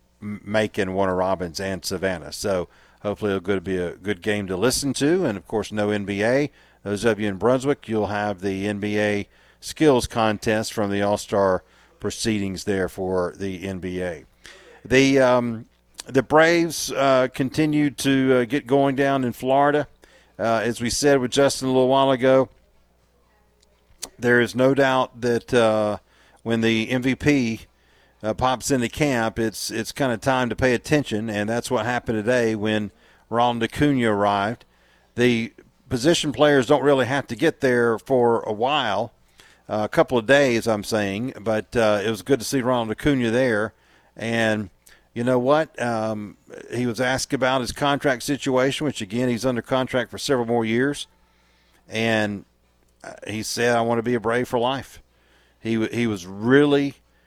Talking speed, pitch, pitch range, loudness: 165 wpm, 115 Hz, 105-130 Hz, -22 LUFS